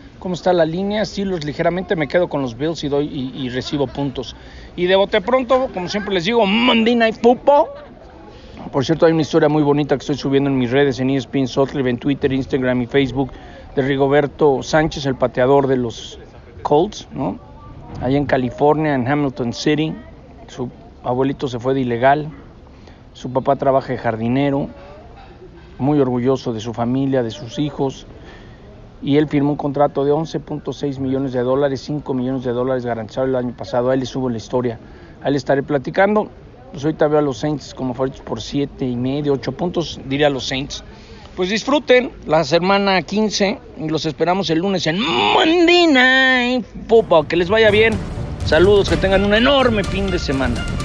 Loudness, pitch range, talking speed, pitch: -18 LUFS, 130-180 Hz, 180 wpm, 145 Hz